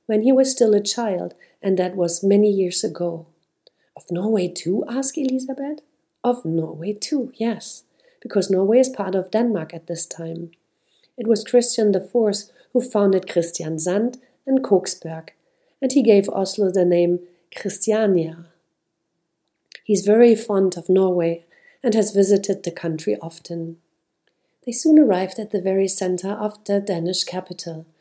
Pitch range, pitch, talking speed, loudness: 170-225 Hz, 195 Hz, 150 wpm, -20 LUFS